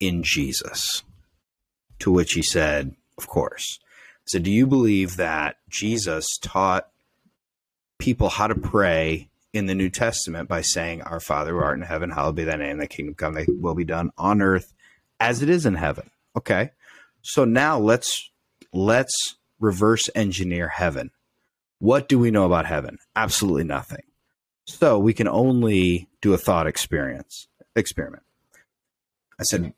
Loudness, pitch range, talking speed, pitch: -22 LUFS, 85-110 Hz, 155 wpm, 95 Hz